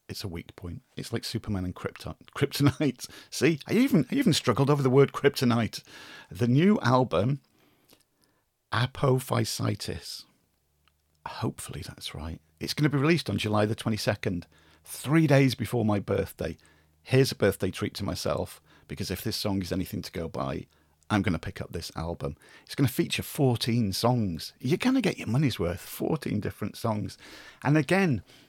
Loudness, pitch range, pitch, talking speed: -28 LUFS, 90-135 Hz, 115 Hz, 175 wpm